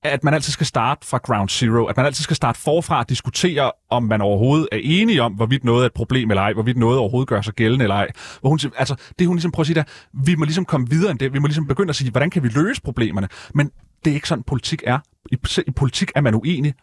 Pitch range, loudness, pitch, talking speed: 115-155 Hz, -19 LUFS, 135 Hz, 285 wpm